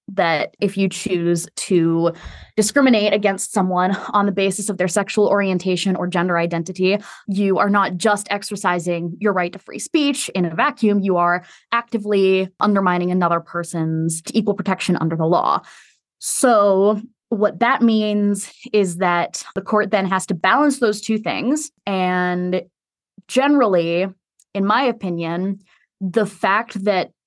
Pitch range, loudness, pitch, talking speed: 180-210 Hz, -19 LUFS, 195 Hz, 145 wpm